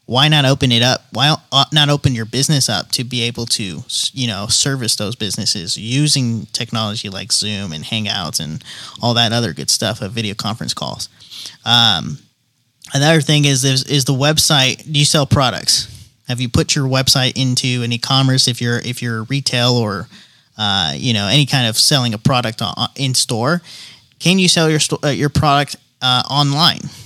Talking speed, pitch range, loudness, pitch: 180 wpm, 115-140 Hz, -15 LUFS, 125 Hz